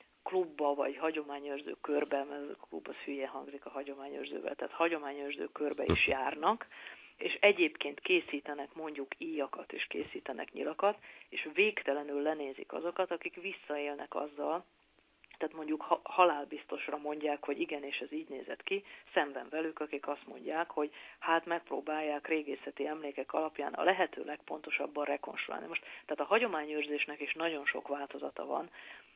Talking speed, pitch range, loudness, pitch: 140 wpm, 145-165 Hz, -36 LUFS, 150 Hz